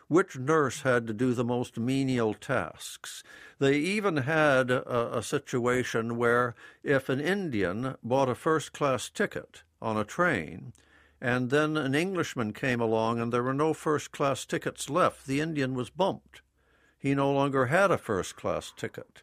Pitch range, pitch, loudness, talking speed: 120-145 Hz, 130 Hz, -28 LUFS, 165 wpm